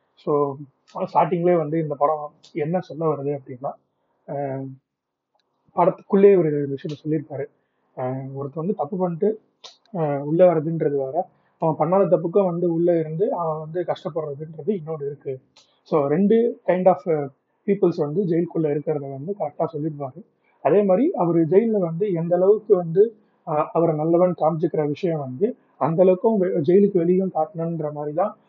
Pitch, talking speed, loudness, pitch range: 165 Hz, 130 wpm, -22 LUFS, 150-185 Hz